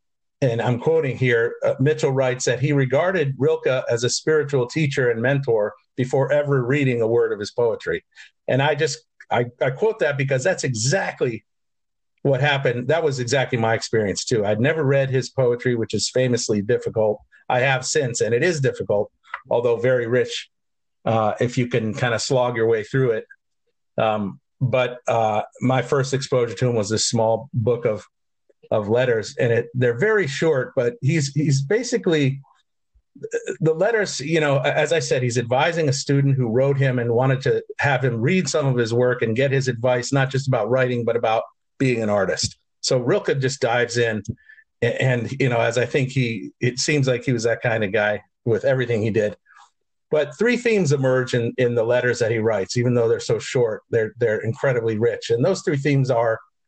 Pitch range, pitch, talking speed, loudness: 120-155 Hz, 130 Hz, 195 wpm, -21 LUFS